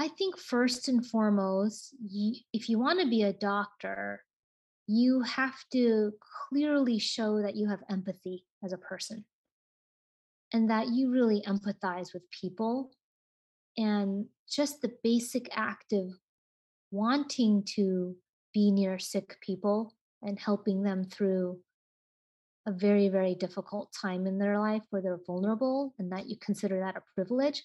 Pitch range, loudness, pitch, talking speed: 195-235 Hz, -31 LUFS, 205 Hz, 145 wpm